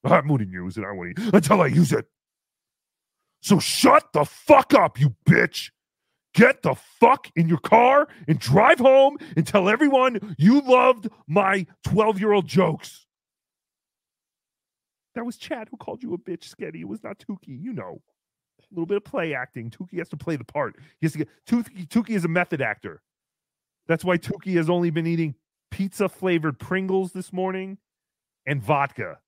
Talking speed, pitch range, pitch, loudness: 175 wpm, 160-215 Hz, 180 Hz, -21 LUFS